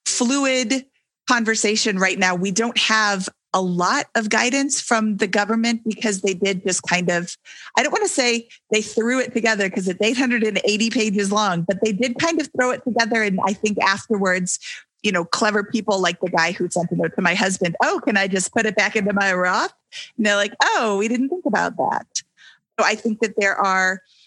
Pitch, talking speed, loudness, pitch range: 215 Hz, 210 wpm, -20 LUFS, 190-235 Hz